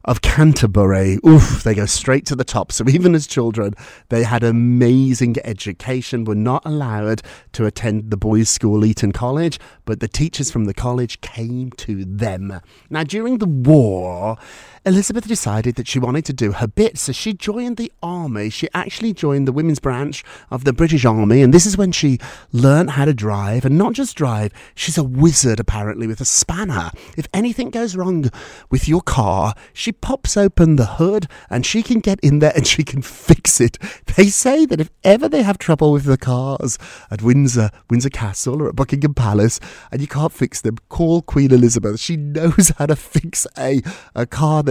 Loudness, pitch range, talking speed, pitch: -16 LUFS, 115-160 Hz, 190 wpm, 135 Hz